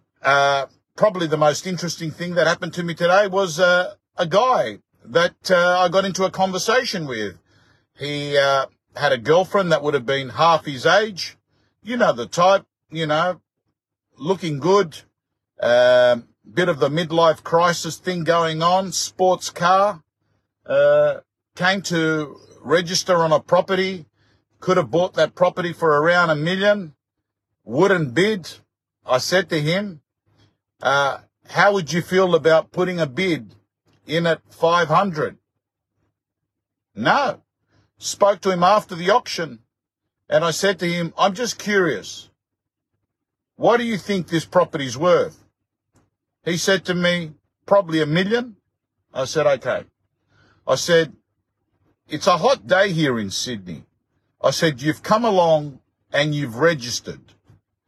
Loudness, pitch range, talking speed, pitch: -19 LUFS, 130-185 Hz, 140 wpm, 165 Hz